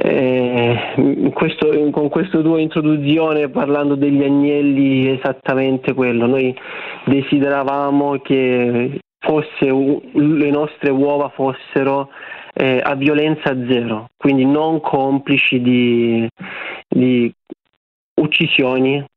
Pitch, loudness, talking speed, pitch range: 140 Hz, -16 LUFS, 90 wpm, 130-150 Hz